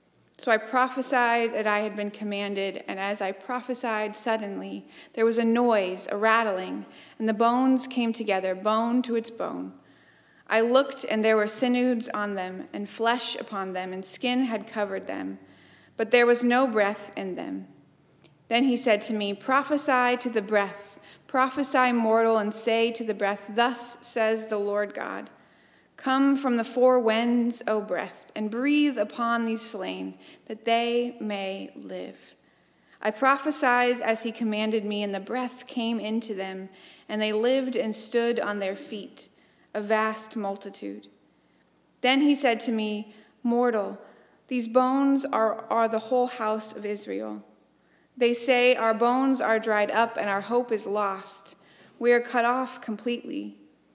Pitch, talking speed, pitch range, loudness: 225 Hz, 160 wpm, 205-245 Hz, -26 LUFS